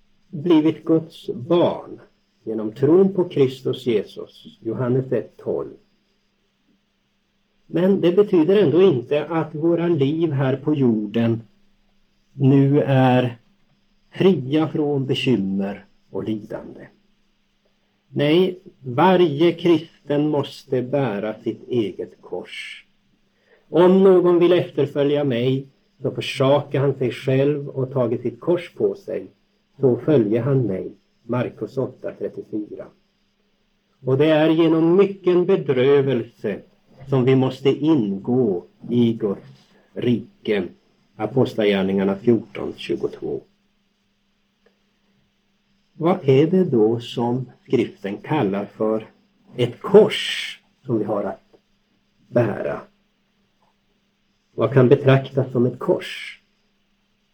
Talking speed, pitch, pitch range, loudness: 100 wpm, 145 Hz, 125-180 Hz, -20 LUFS